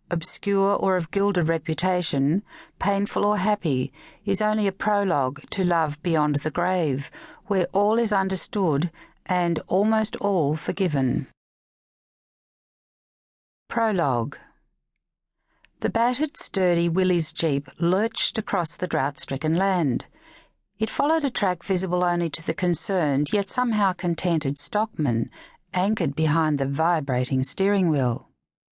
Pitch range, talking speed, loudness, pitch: 155-200 Hz, 115 wpm, -23 LUFS, 180 Hz